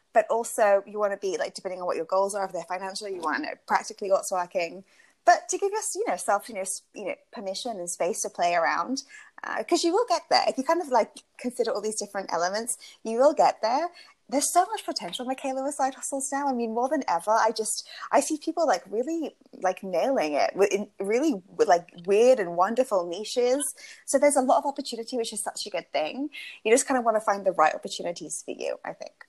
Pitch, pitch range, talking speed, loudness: 230 Hz, 195-285 Hz, 240 wpm, -26 LUFS